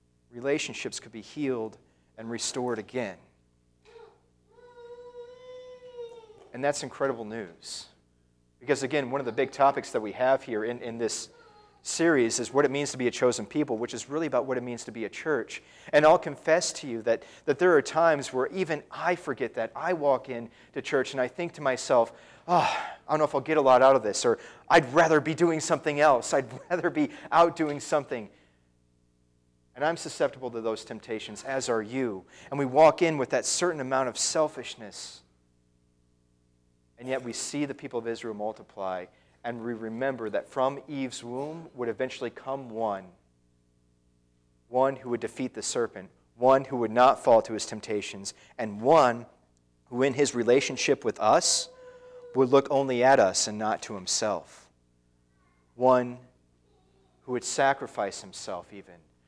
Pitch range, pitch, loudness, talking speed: 100-150 Hz, 125 Hz, -27 LUFS, 175 wpm